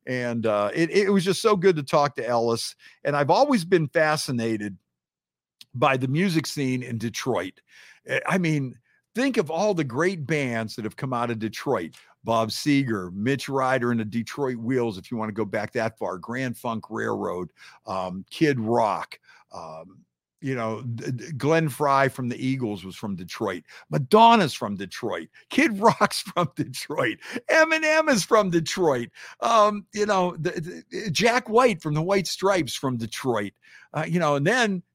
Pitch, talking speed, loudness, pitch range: 140 Hz, 170 wpm, -24 LUFS, 115-180 Hz